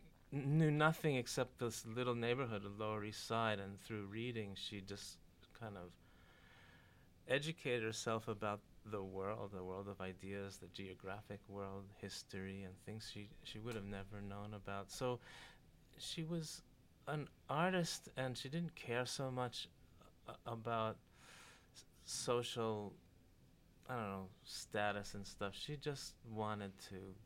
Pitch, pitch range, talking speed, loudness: 110 Hz, 100-125 Hz, 135 wpm, -44 LUFS